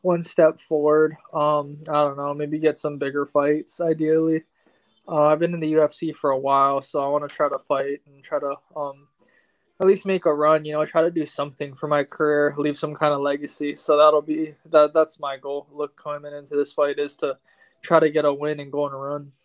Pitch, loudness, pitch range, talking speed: 150 Hz, -22 LUFS, 145-155 Hz, 235 wpm